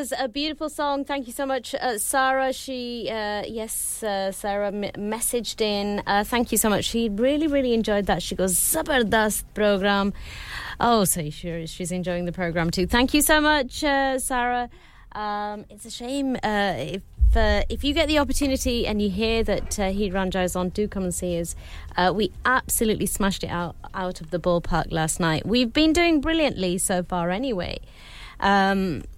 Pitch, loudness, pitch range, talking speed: 210 Hz, -23 LUFS, 185-260 Hz, 185 wpm